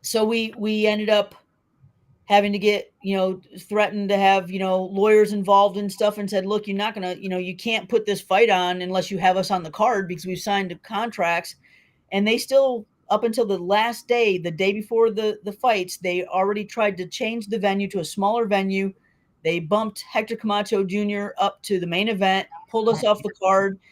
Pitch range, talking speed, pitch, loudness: 185-215 Hz, 215 wpm, 200 Hz, -22 LUFS